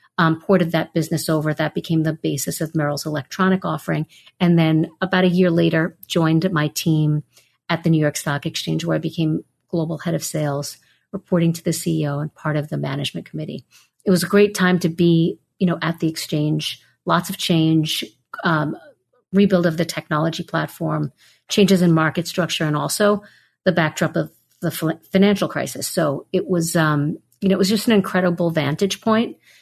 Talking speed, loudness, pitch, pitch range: 185 wpm, -20 LUFS, 165 Hz, 155-185 Hz